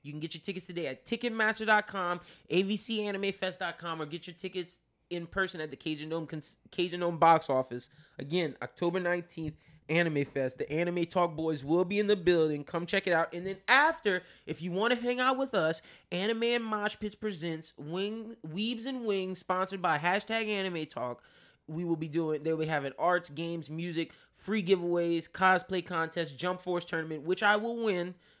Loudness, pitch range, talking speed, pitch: -31 LUFS, 160-195 Hz, 180 wpm, 175 Hz